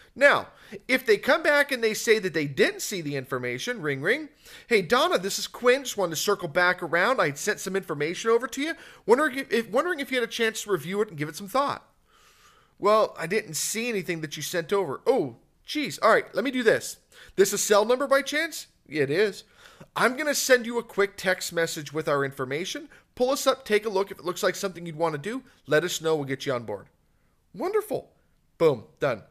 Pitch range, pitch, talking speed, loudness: 170-260 Hz, 210 Hz, 235 wpm, -25 LUFS